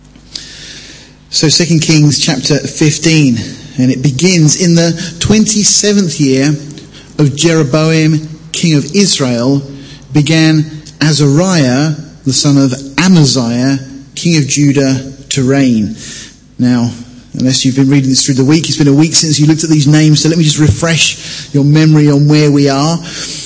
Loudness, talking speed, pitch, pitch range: -9 LUFS, 150 wpm, 150 Hz, 135-160 Hz